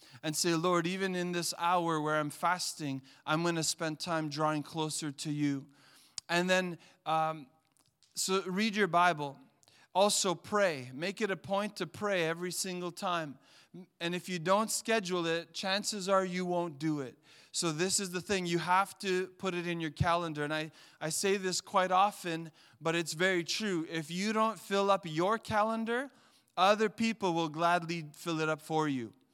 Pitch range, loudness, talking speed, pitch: 155-190 Hz, -32 LUFS, 180 wpm, 175 Hz